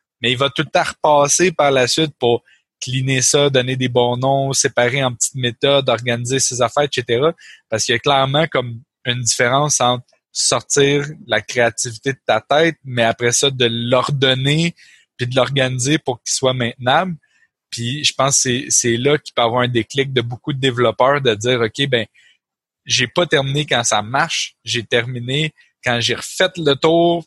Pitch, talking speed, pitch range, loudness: 130 Hz, 185 wpm, 120-145 Hz, -16 LUFS